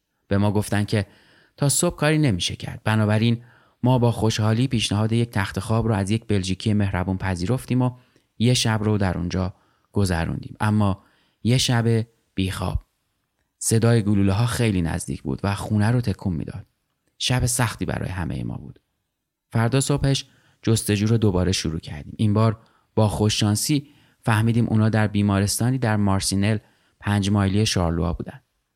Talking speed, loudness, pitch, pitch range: 150 wpm, -22 LUFS, 110 Hz, 100-120 Hz